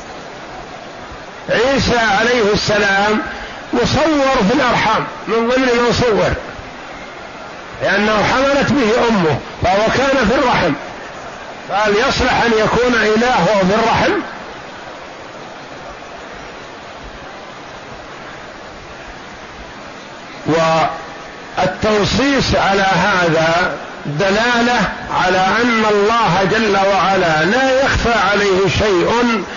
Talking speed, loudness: 75 wpm, -14 LUFS